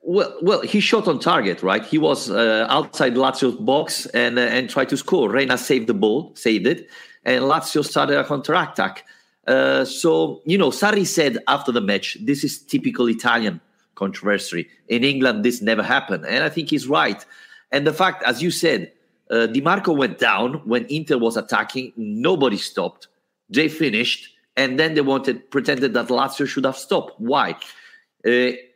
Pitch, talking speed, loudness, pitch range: 135 Hz, 175 wpm, -20 LUFS, 115-155 Hz